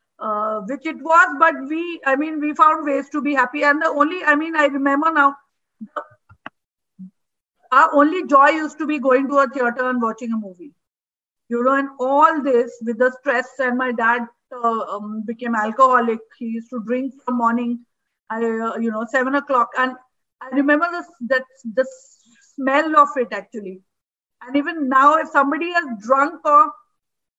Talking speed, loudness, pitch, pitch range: 180 wpm, -18 LUFS, 265 Hz, 235-295 Hz